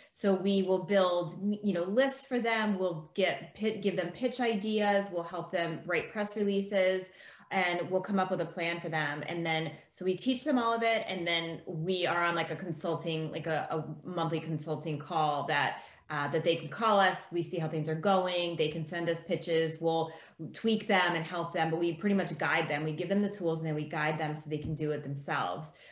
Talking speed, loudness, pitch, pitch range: 230 wpm, -32 LUFS, 170 Hz, 160-195 Hz